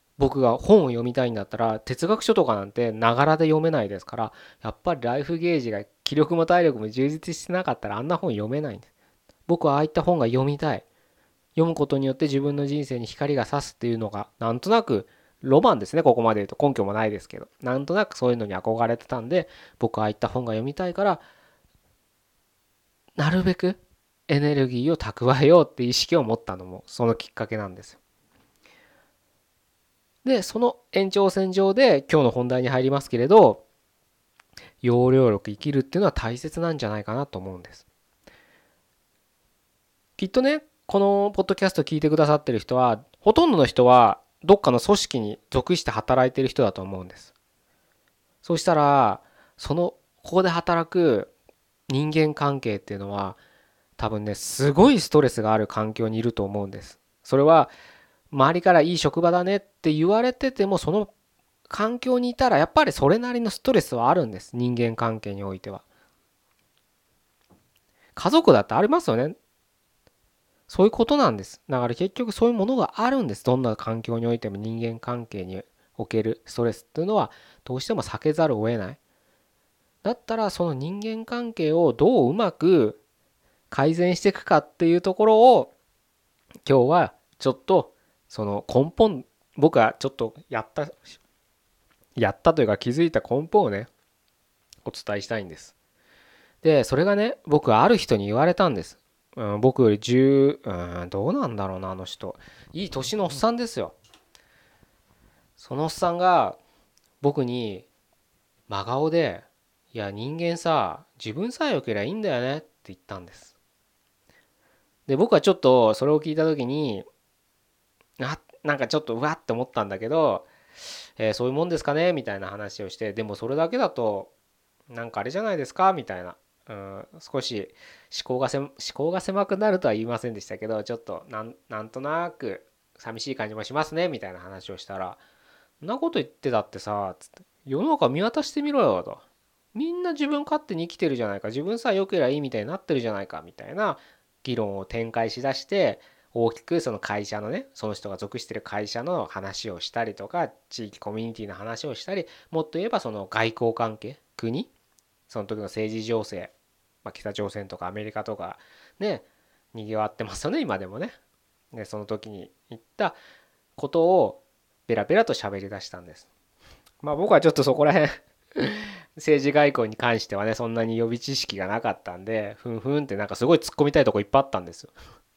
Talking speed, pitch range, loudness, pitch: 355 characters per minute, 110-170 Hz, -23 LUFS, 130 Hz